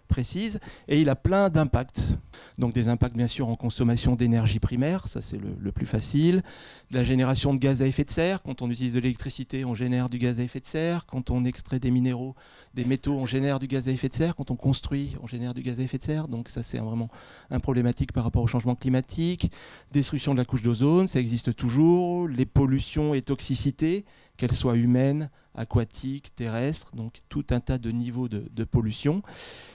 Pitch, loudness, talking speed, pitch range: 130 Hz, -26 LUFS, 210 wpm, 120-140 Hz